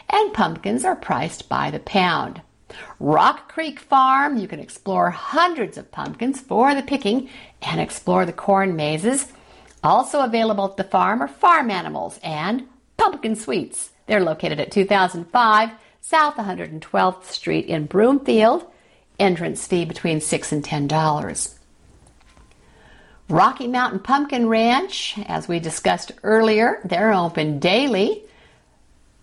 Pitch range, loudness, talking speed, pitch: 185-270 Hz, -20 LUFS, 125 wpm, 220 Hz